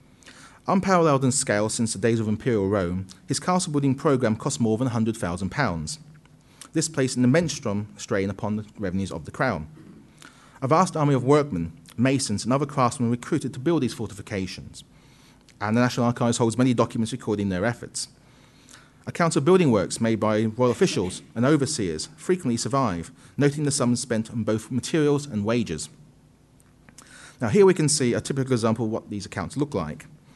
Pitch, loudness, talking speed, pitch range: 120 Hz, -24 LUFS, 170 wpm, 105-140 Hz